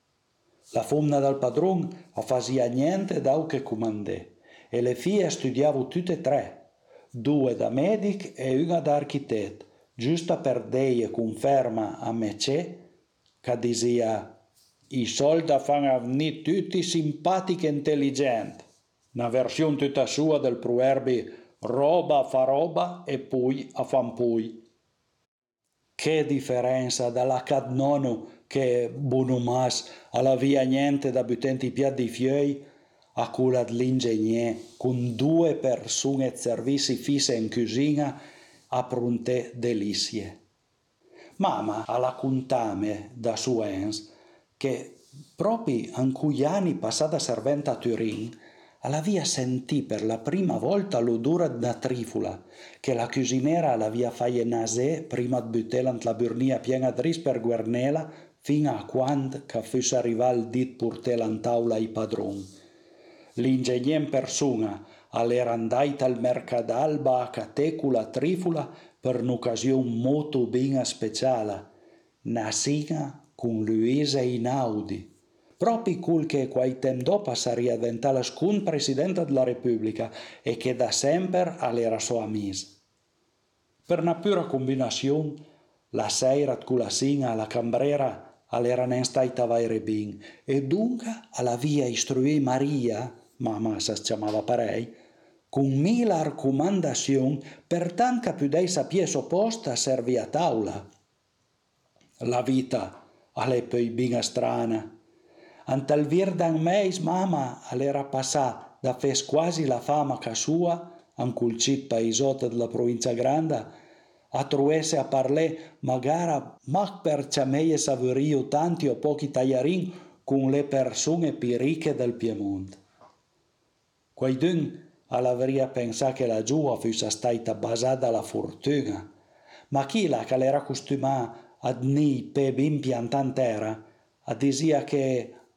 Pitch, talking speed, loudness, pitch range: 130 Hz, 120 wpm, -26 LUFS, 120-150 Hz